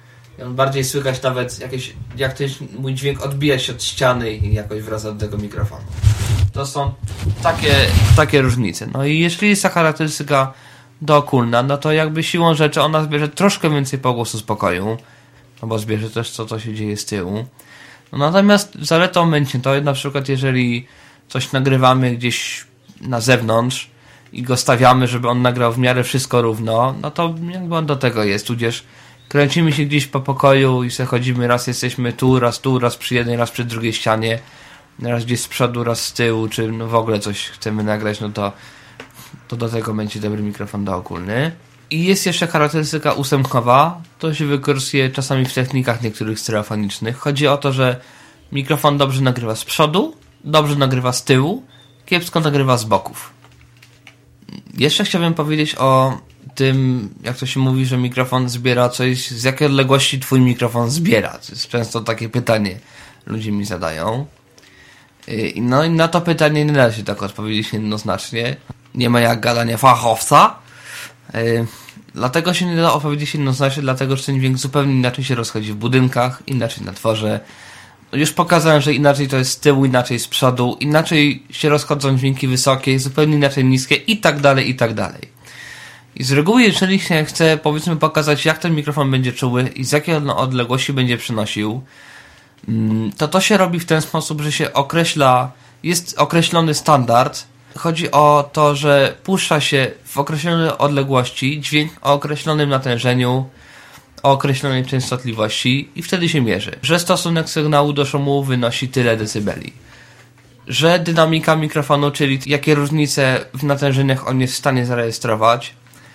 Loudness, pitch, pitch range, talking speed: -17 LUFS, 130 Hz, 120-145 Hz, 160 wpm